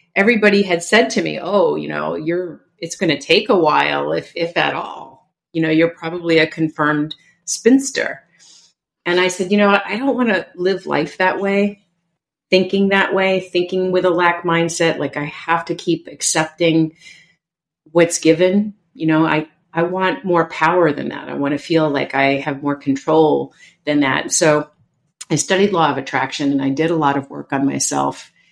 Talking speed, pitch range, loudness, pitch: 190 wpm, 150-185 Hz, -17 LUFS, 165 Hz